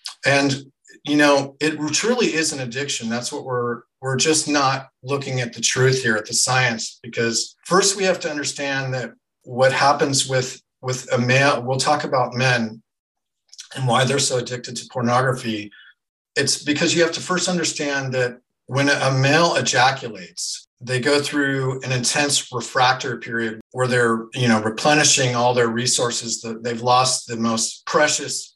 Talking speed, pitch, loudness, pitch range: 165 wpm, 130 Hz, -20 LUFS, 120-145 Hz